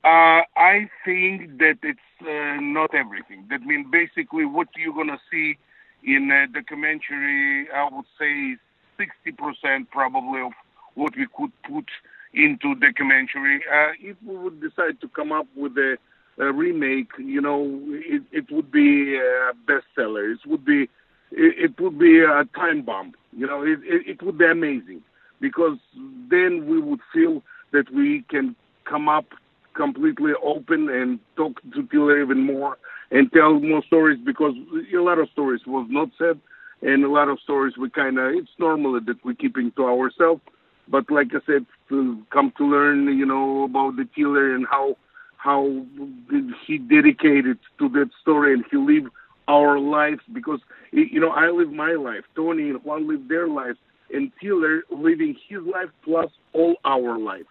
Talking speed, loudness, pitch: 170 wpm, -21 LUFS, 160 Hz